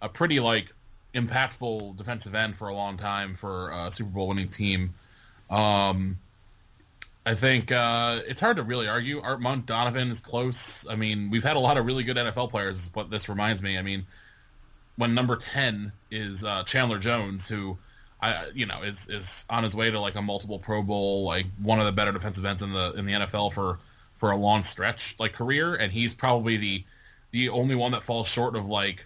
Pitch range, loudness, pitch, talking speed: 100-120 Hz, -27 LUFS, 105 Hz, 205 wpm